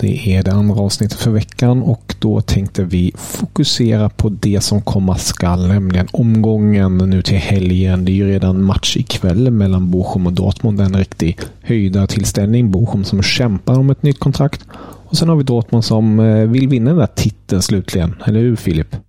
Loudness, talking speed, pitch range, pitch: -14 LUFS, 180 wpm, 95-115 Hz, 105 Hz